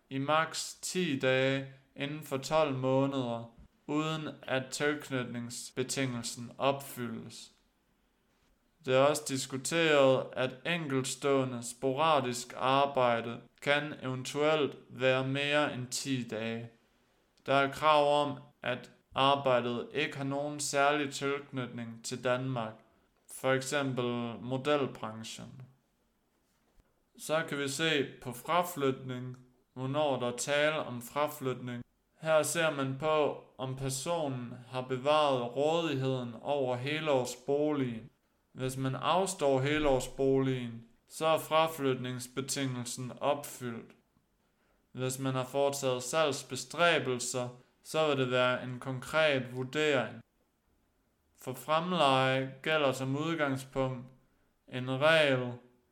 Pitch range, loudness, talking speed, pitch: 125-145 Hz, -32 LUFS, 100 wpm, 135 Hz